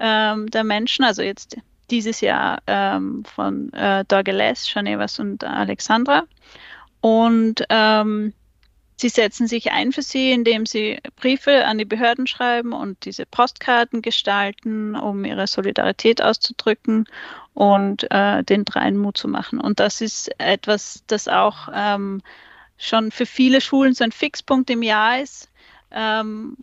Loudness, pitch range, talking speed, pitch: -19 LUFS, 210-245 Hz, 135 wpm, 225 Hz